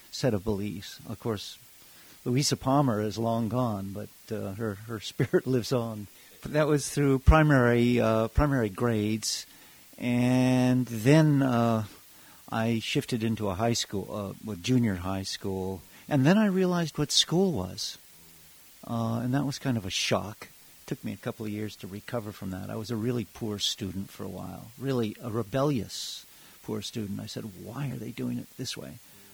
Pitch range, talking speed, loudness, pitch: 105-130 Hz, 180 wpm, -28 LUFS, 115 Hz